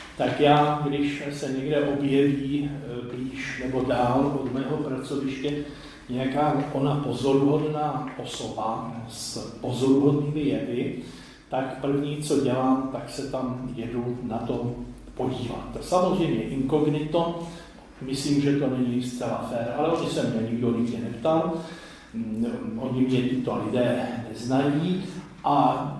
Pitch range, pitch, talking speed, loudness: 125-145 Hz, 135 Hz, 120 wpm, -26 LUFS